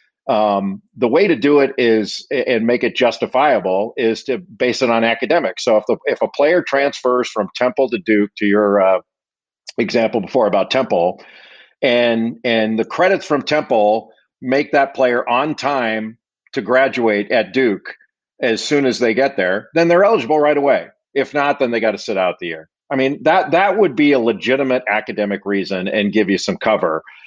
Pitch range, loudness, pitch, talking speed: 105-140 Hz, -16 LUFS, 120 Hz, 190 wpm